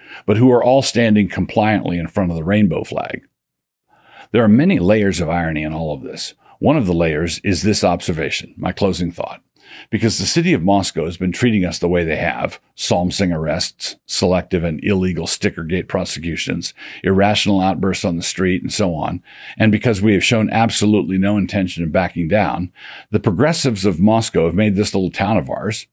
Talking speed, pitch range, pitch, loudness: 190 wpm, 90-105 Hz, 100 Hz, -17 LUFS